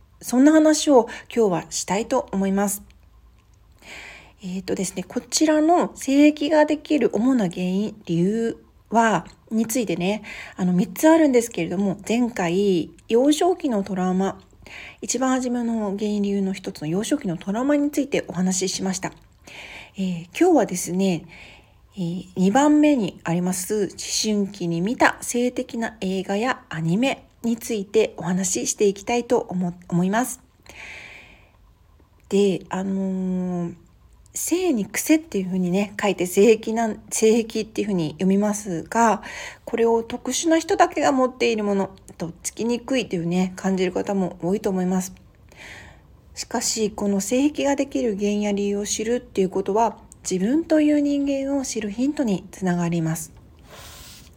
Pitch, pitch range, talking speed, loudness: 205 Hz, 185-245 Hz, 300 characters per minute, -22 LUFS